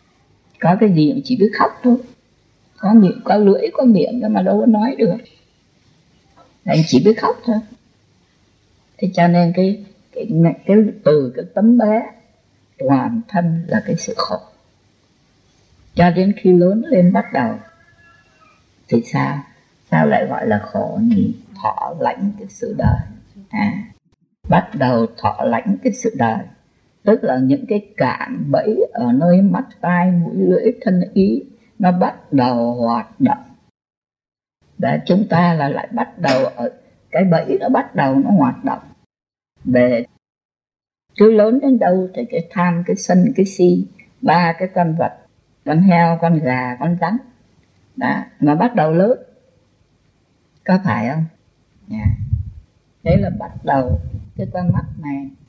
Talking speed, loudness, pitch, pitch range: 155 wpm, -16 LUFS, 195 Hz, 170-225 Hz